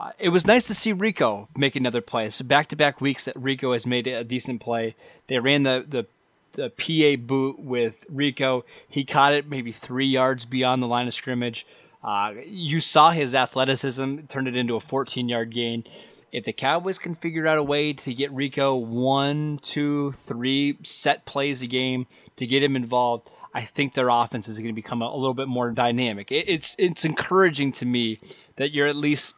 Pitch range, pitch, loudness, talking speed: 125-145 Hz, 135 Hz, -24 LUFS, 200 wpm